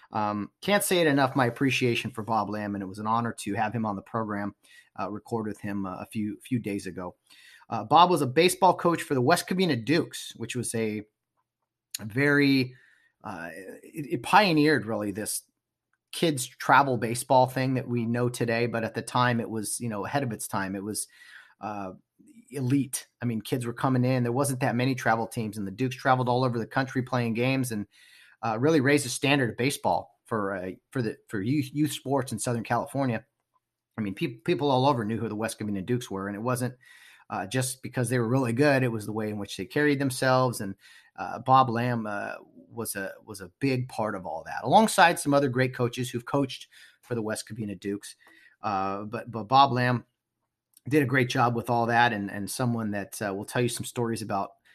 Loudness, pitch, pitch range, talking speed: -27 LUFS, 120 Hz, 110-135 Hz, 215 wpm